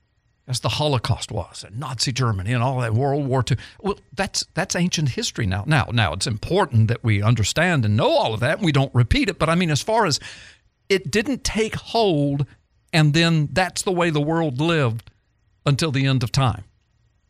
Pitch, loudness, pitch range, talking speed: 135 Hz, -21 LUFS, 110-165 Hz, 205 wpm